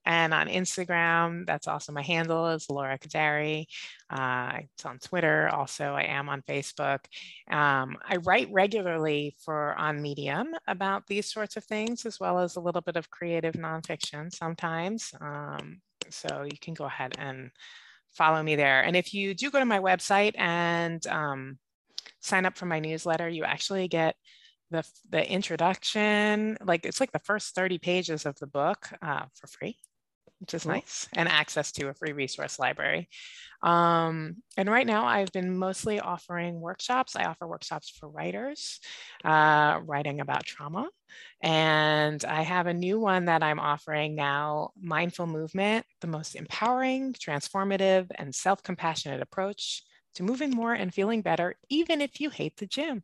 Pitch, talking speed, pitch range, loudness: 170 Hz, 165 wpm, 150-195 Hz, -28 LUFS